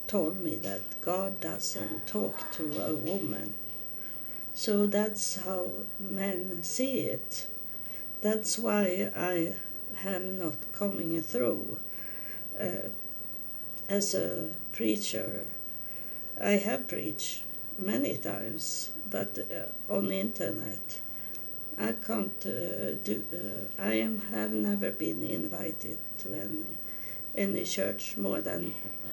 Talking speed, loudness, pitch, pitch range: 110 wpm, -32 LUFS, 190 Hz, 170-205 Hz